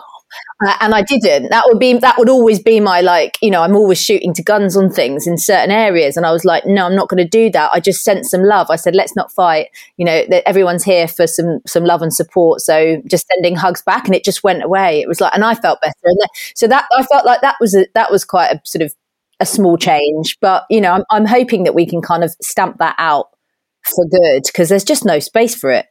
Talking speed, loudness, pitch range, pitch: 265 wpm, -12 LUFS, 175-220 Hz, 190 Hz